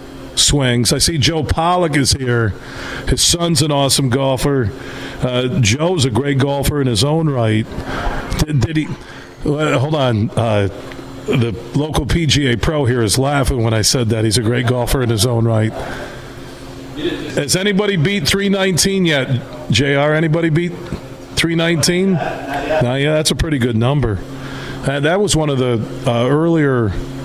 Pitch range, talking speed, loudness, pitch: 120-155 Hz, 160 wpm, -16 LUFS, 140 Hz